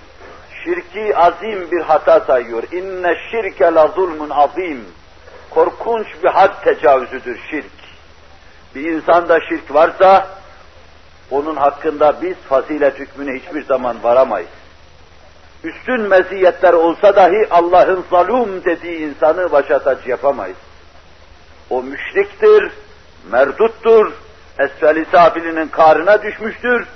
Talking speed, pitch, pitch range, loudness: 100 wpm, 165 Hz, 135-195 Hz, -14 LUFS